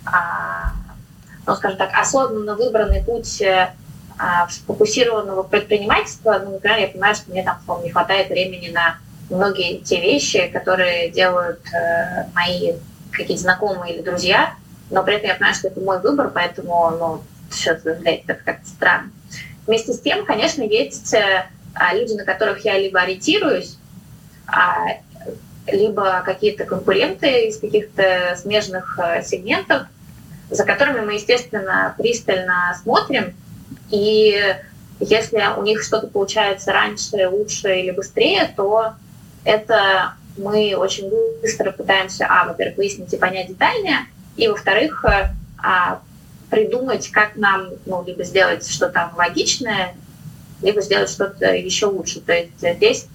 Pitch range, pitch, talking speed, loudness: 180-215 Hz, 195 Hz, 120 wpm, -18 LUFS